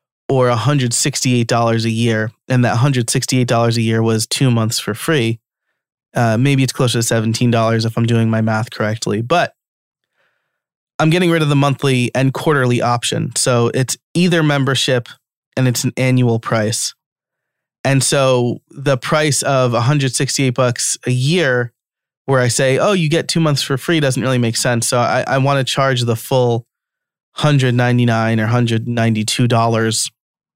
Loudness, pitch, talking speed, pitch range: -15 LUFS, 125 Hz, 185 wpm, 115-135 Hz